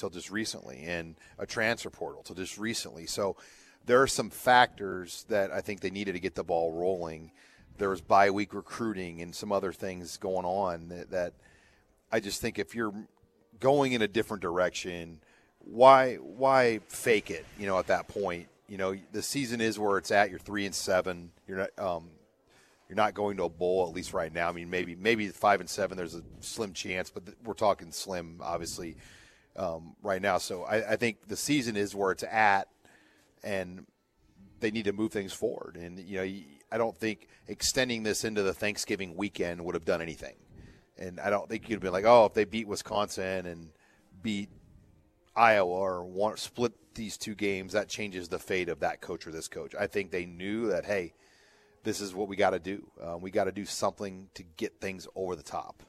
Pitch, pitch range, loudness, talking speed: 100 Hz, 90-110 Hz, -30 LUFS, 205 wpm